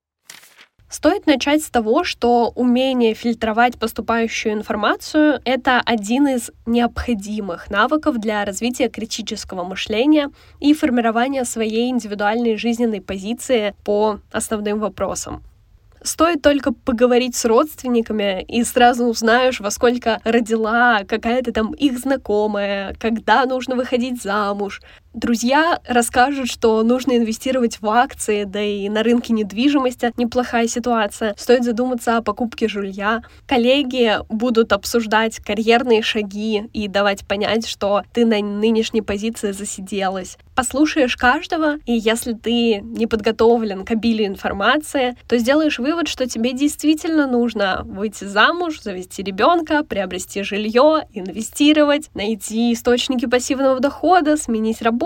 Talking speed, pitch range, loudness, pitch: 120 wpm, 215-255 Hz, -18 LUFS, 235 Hz